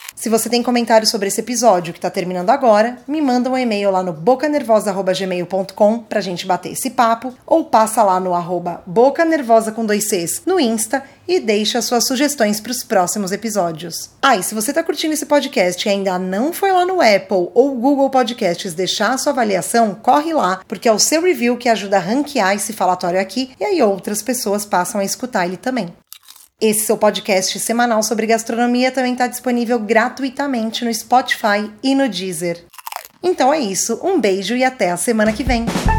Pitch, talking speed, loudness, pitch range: 225 Hz, 190 wpm, -17 LUFS, 195-255 Hz